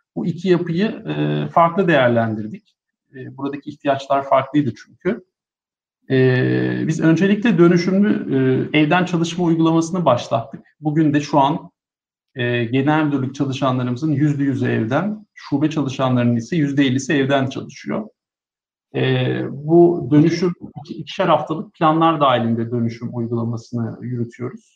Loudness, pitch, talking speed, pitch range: -18 LUFS, 145 Hz, 105 wpm, 120-165 Hz